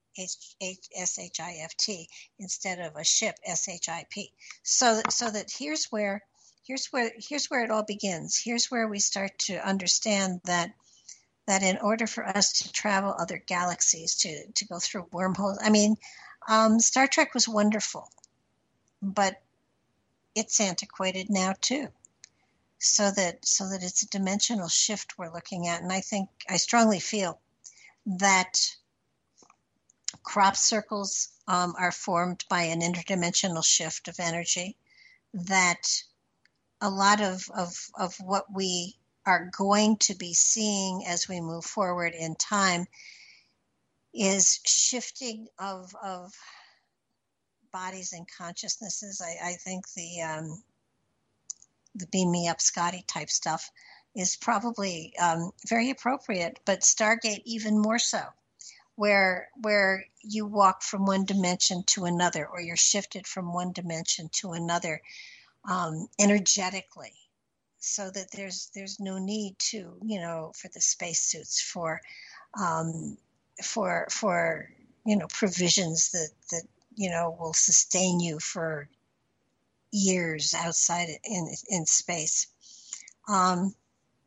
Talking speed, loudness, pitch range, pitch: 135 wpm, -27 LUFS, 175-210 Hz, 190 Hz